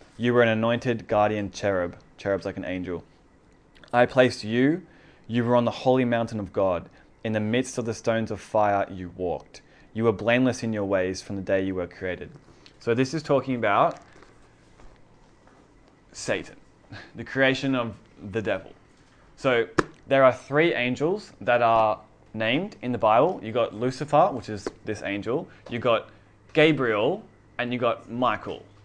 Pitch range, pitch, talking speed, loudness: 105-125 Hz, 115 Hz, 165 wpm, -25 LUFS